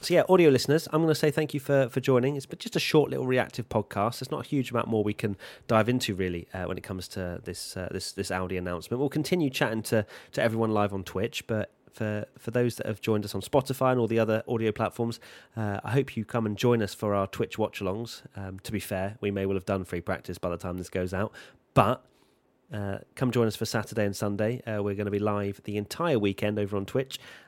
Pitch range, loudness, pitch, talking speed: 100-125 Hz, -28 LUFS, 110 Hz, 260 wpm